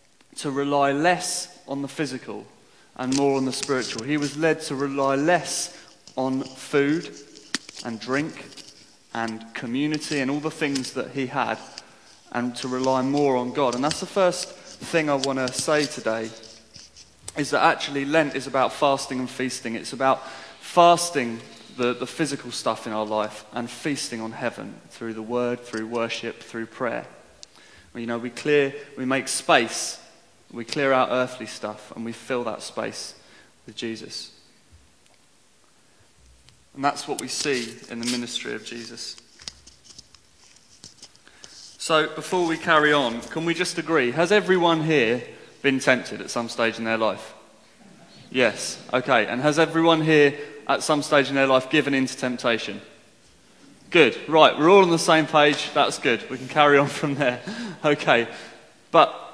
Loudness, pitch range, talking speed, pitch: -23 LUFS, 120-150 Hz, 160 wpm, 135 Hz